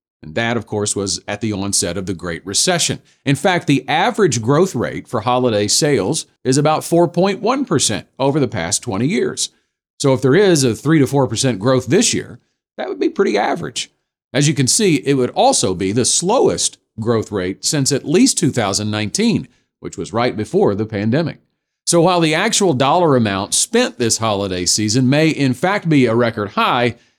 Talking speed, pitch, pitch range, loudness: 185 wpm, 125 Hz, 105-155 Hz, -16 LUFS